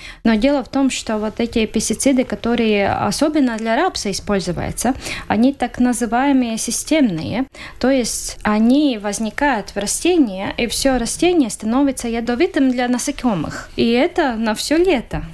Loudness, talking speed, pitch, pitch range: -18 LUFS, 135 wpm, 245 Hz, 220-275 Hz